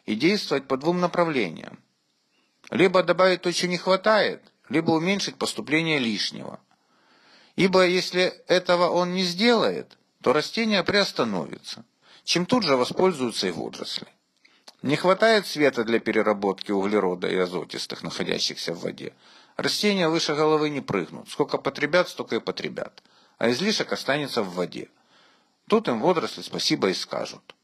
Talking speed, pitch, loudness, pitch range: 135 wpm, 175 Hz, -24 LUFS, 140-190 Hz